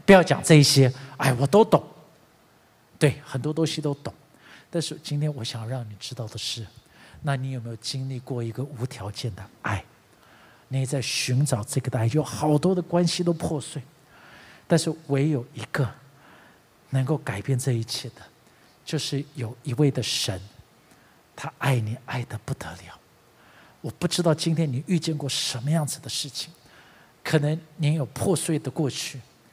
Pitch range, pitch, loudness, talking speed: 125-155 Hz, 135 Hz, -25 LUFS, 235 characters per minute